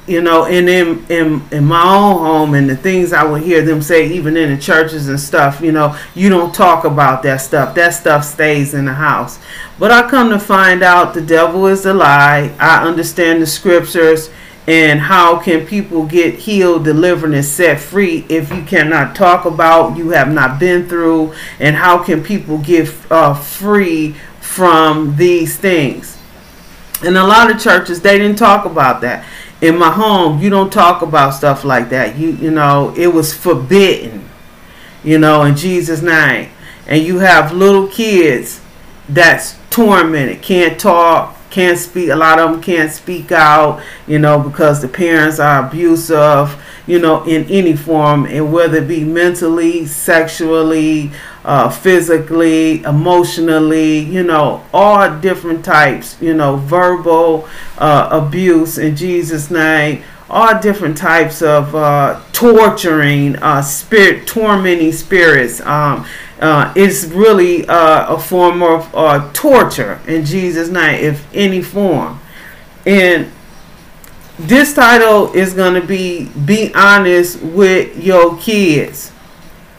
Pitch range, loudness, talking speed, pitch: 155-180 Hz, -10 LUFS, 150 wpm, 165 Hz